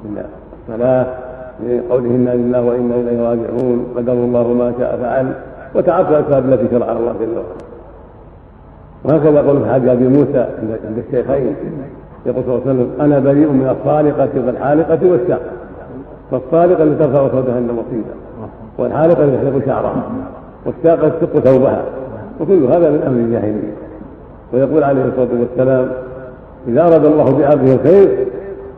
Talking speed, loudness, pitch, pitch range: 130 wpm, -14 LUFS, 130 Hz, 120-145 Hz